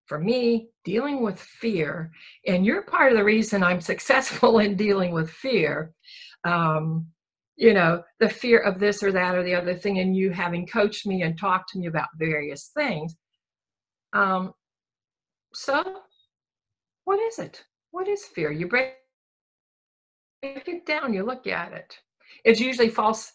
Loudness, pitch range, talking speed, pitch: -24 LUFS, 170-235 Hz, 155 wpm, 195 Hz